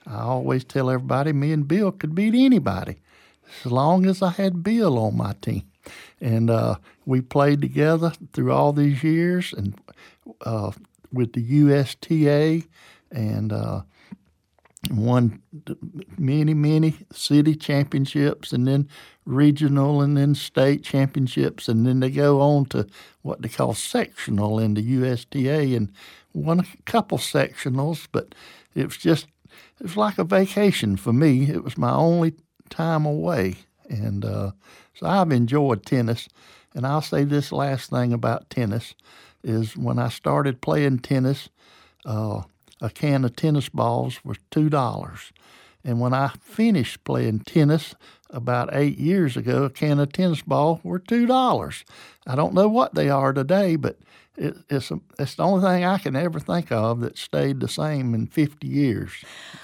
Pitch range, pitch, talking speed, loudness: 120-160 Hz, 140 Hz, 155 wpm, -22 LUFS